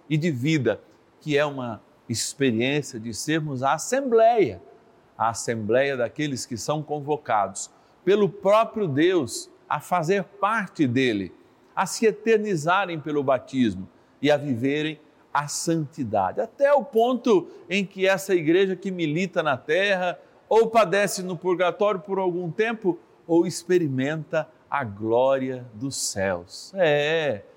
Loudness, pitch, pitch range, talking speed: -24 LUFS, 170 Hz, 140-200 Hz, 130 wpm